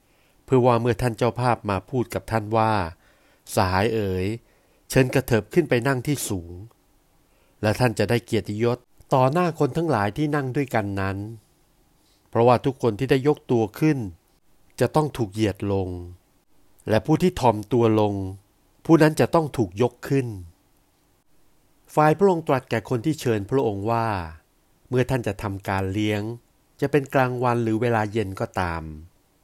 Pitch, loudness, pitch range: 115 Hz, -23 LUFS, 100-130 Hz